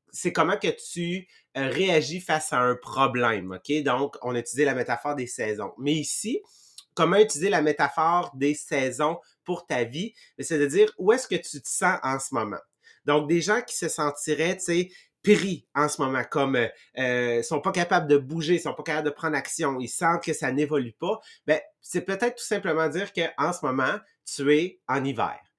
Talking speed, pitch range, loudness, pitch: 200 wpm, 135-180 Hz, -26 LUFS, 155 Hz